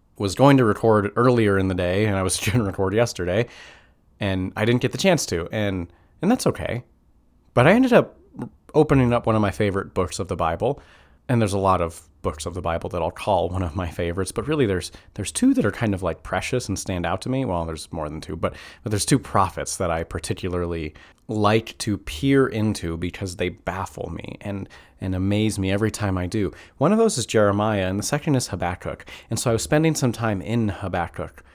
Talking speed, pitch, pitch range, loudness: 230 wpm, 100 Hz, 90-115 Hz, -23 LUFS